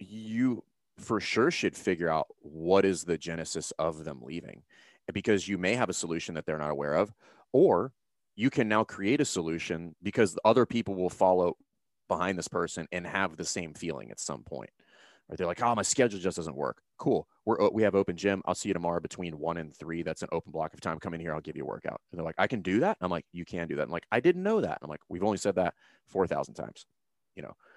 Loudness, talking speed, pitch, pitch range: -30 LUFS, 255 wpm, 90 Hz, 85-100 Hz